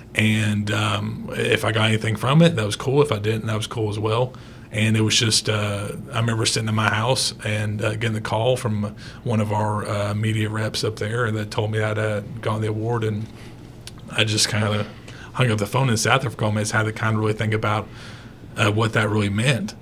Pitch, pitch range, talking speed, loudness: 110 Hz, 105-115 Hz, 245 wpm, -22 LUFS